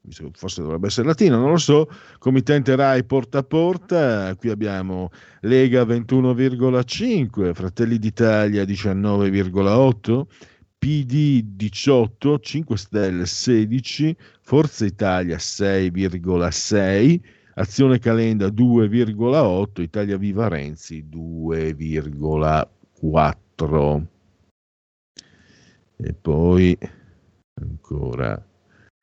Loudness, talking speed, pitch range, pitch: -20 LUFS, 75 wpm, 90-130 Hz, 105 Hz